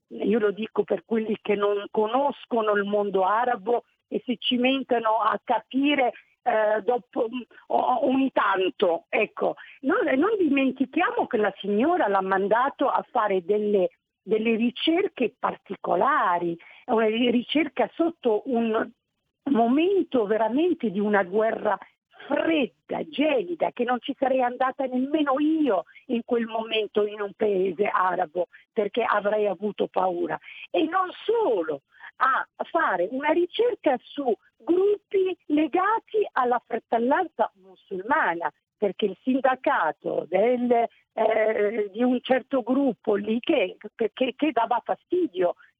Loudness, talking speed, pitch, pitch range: -25 LUFS, 125 wpm, 240 Hz, 210-285 Hz